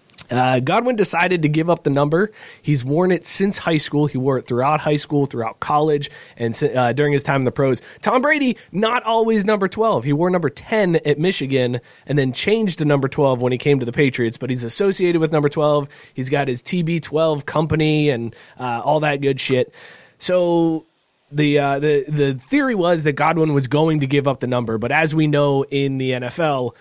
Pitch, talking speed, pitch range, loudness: 150 Hz, 215 wpm, 135-170 Hz, -18 LUFS